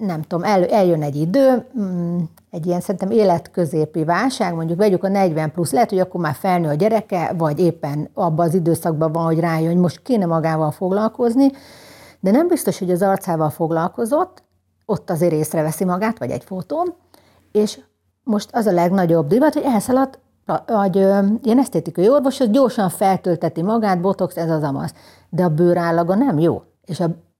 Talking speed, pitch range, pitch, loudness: 170 wpm, 165-215 Hz, 185 Hz, -18 LUFS